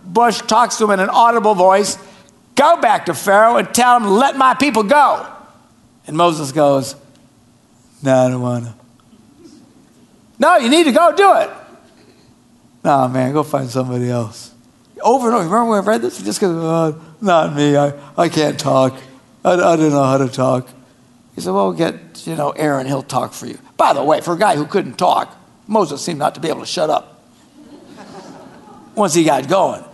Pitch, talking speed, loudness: 175 Hz, 200 wpm, -15 LUFS